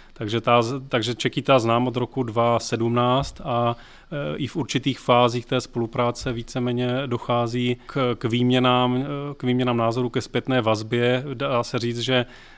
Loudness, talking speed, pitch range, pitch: -23 LUFS, 150 wpm, 120-130 Hz, 125 Hz